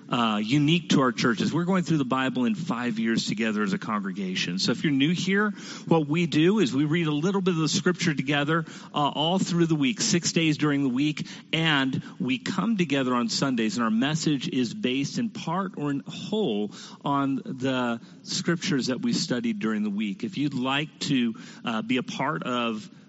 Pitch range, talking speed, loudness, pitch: 140-195 Hz, 205 wpm, -26 LUFS, 160 Hz